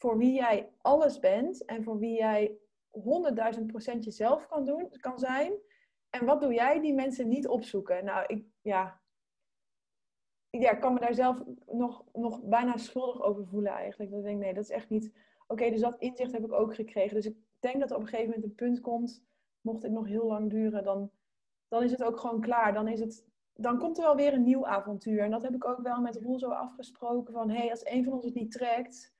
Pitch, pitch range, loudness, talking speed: 235 Hz, 215-255 Hz, -31 LUFS, 230 wpm